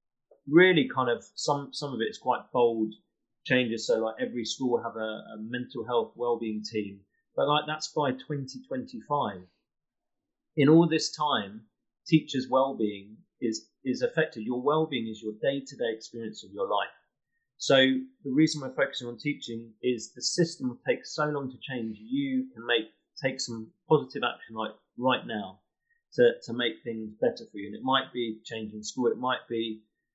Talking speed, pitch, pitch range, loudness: 185 wpm, 130 Hz, 115-150 Hz, -29 LUFS